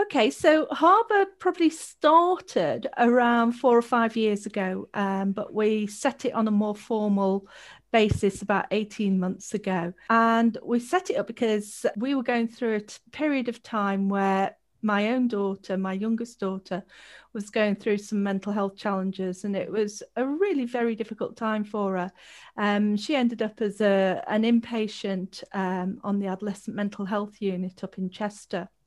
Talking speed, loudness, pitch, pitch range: 170 wpm, -26 LUFS, 215 Hz, 200-235 Hz